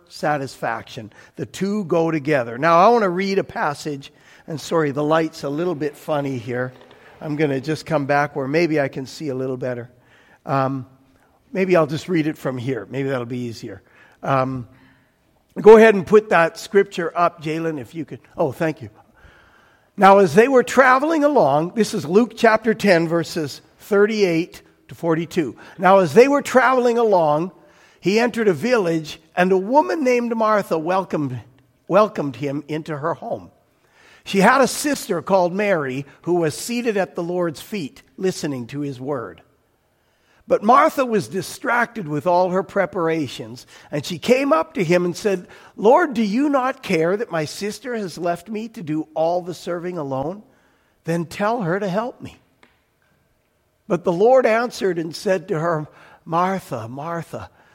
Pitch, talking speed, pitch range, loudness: 170 Hz, 170 wpm, 150-205 Hz, -19 LUFS